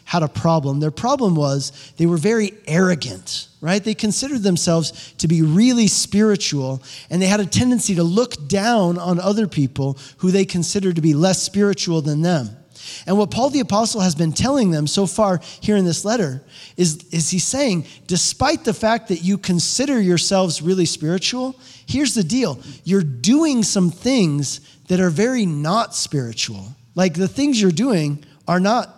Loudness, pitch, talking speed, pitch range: -18 LUFS, 180 Hz, 175 wpm, 155-210 Hz